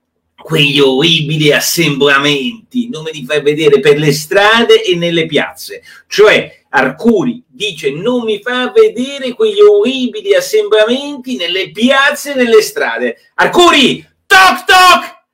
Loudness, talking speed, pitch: -10 LUFS, 125 wpm, 235 Hz